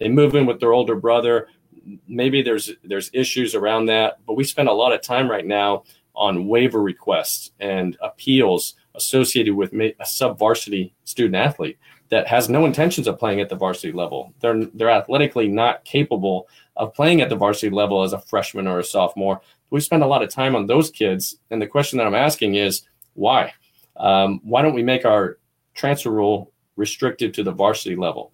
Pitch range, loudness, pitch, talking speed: 100-130 Hz, -20 LUFS, 115 Hz, 195 wpm